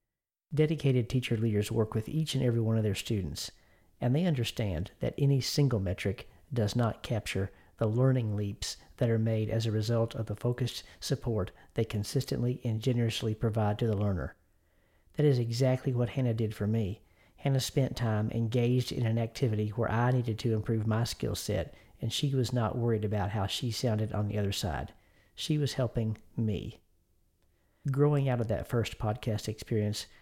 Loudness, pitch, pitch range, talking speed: -31 LUFS, 115 Hz, 105-125 Hz, 180 wpm